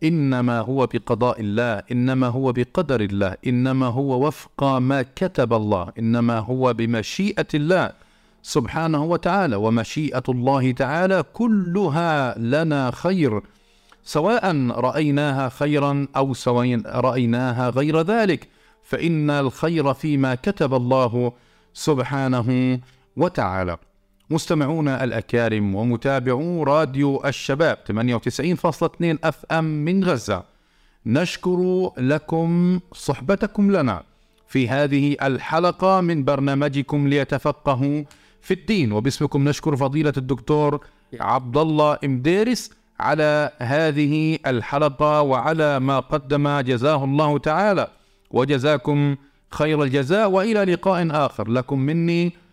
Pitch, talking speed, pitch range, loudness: 140 Hz, 100 wpm, 125-160 Hz, -21 LUFS